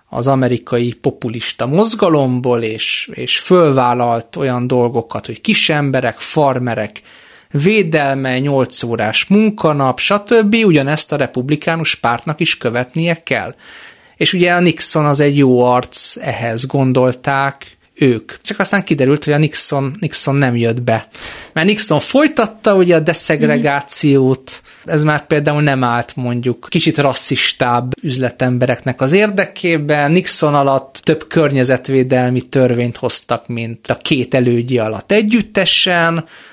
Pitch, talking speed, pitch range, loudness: 140 Hz, 125 wpm, 125-165 Hz, -14 LUFS